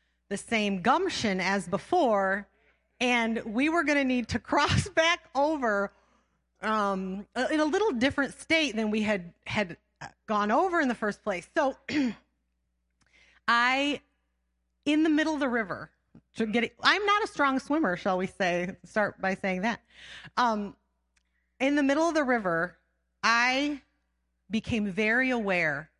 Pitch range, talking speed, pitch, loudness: 195-280 Hz, 150 wpm, 225 Hz, -27 LUFS